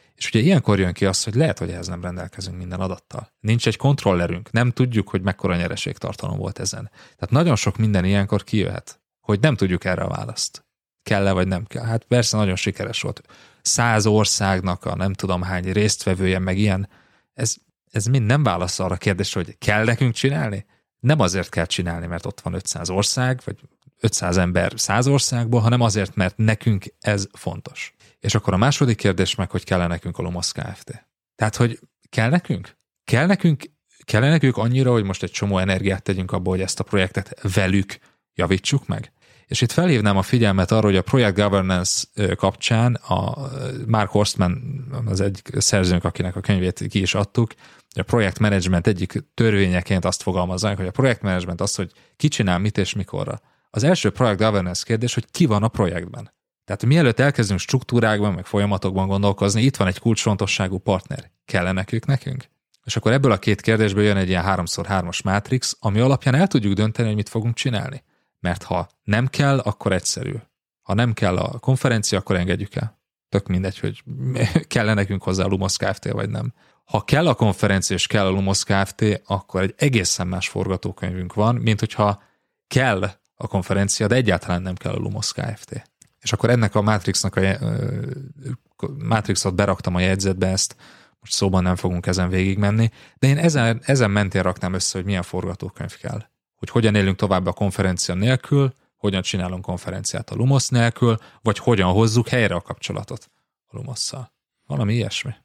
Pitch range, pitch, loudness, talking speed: 95-120 Hz, 105 Hz, -21 LUFS, 180 wpm